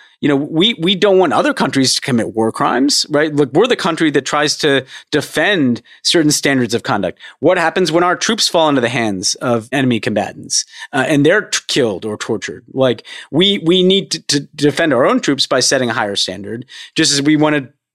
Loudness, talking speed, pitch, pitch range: -14 LUFS, 215 wpm, 145 Hz, 125-170 Hz